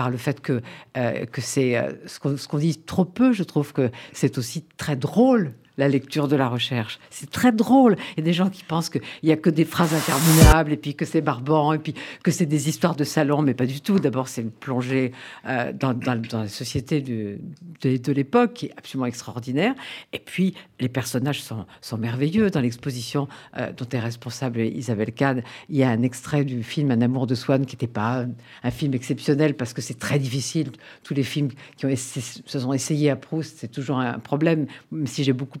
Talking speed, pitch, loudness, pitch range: 230 wpm, 140 Hz, -23 LUFS, 125-155 Hz